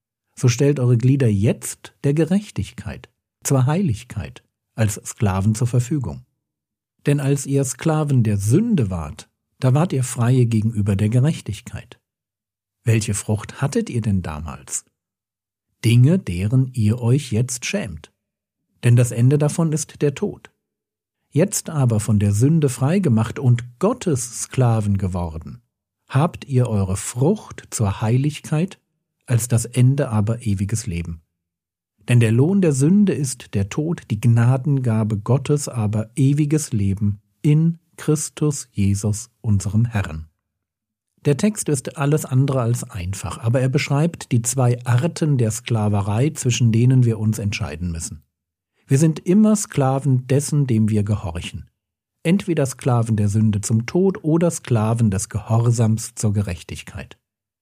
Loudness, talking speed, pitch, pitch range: -20 LUFS, 135 wpm, 120 Hz, 105-140 Hz